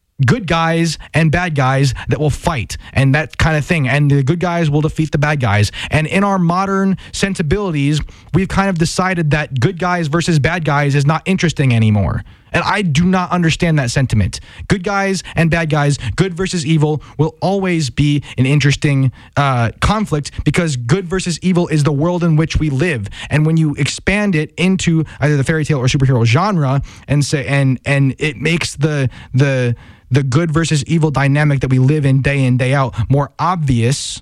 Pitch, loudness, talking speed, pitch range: 150 Hz, -15 LUFS, 195 wpm, 135-170 Hz